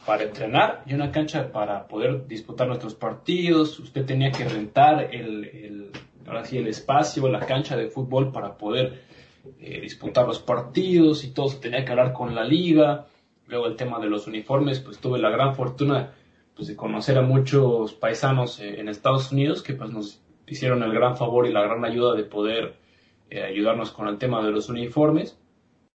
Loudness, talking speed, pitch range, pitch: -24 LUFS, 180 wpm, 110-140 Hz, 125 Hz